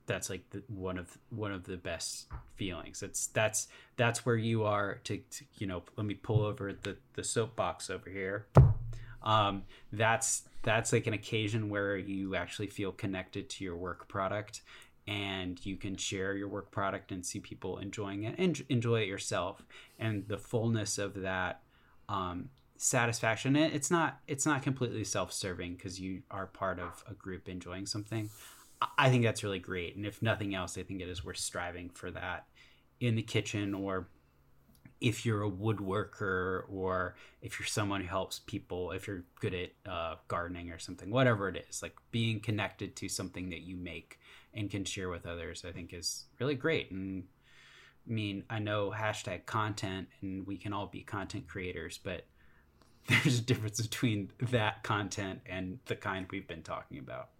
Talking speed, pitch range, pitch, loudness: 180 wpm, 95-110 Hz, 100 Hz, -35 LUFS